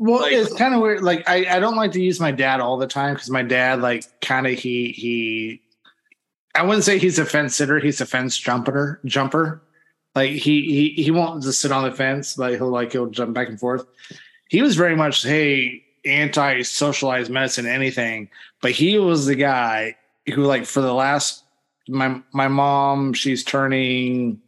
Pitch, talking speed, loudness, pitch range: 135 Hz, 195 wpm, -19 LUFS, 125-150 Hz